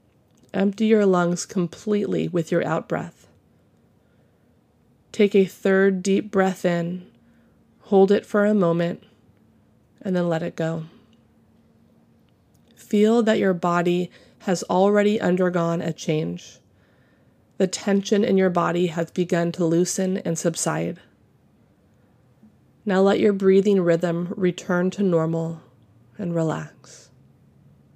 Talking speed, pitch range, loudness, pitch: 115 wpm, 170-195 Hz, -22 LUFS, 180 Hz